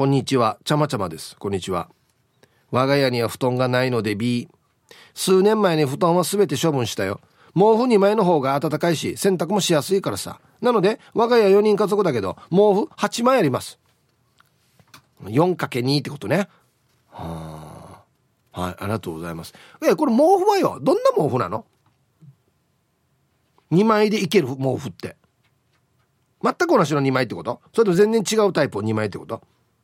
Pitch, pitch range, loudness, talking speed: 150 Hz, 125-205 Hz, -20 LUFS, 305 characters per minute